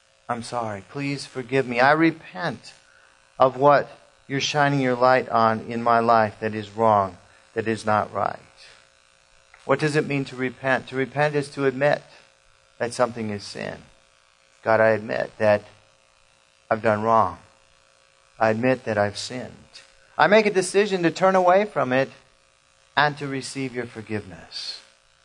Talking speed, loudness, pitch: 155 wpm, -22 LUFS, 110 Hz